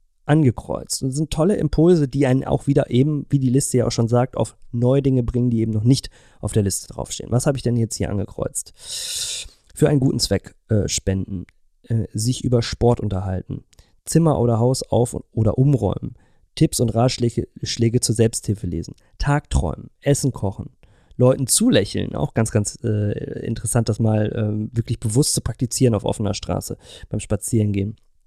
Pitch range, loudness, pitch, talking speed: 105-135 Hz, -21 LUFS, 120 Hz, 175 wpm